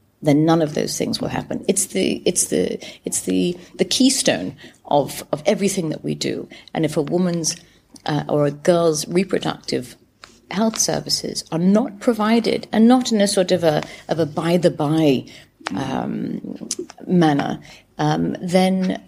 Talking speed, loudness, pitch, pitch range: 155 wpm, -20 LUFS, 175 Hz, 150-200 Hz